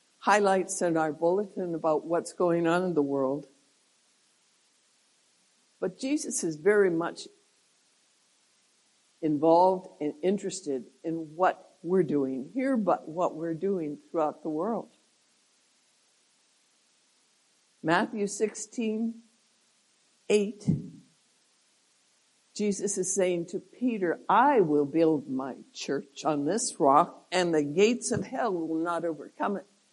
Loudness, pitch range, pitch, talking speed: -28 LUFS, 160-210 Hz, 180 Hz, 110 wpm